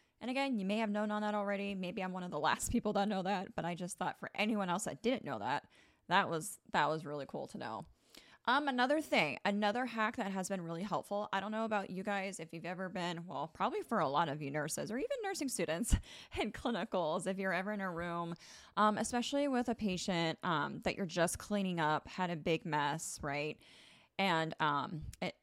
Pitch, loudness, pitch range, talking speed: 190 Hz, -37 LUFS, 165-210 Hz, 230 wpm